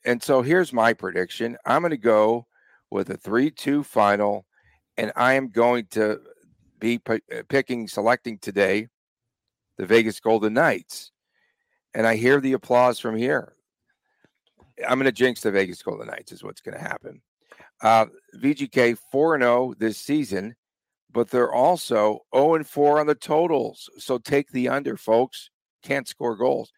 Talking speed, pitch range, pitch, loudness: 155 wpm, 110-135 Hz, 120 Hz, -22 LUFS